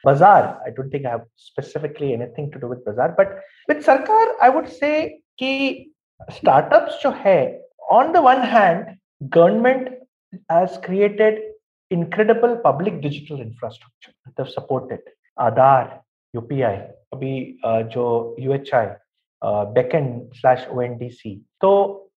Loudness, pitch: -18 LUFS, 170 Hz